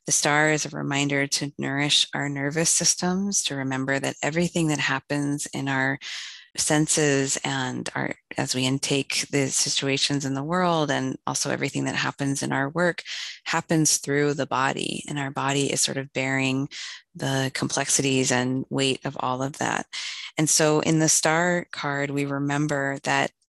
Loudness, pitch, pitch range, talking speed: -24 LUFS, 140 Hz, 135-155 Hz, 165 wpm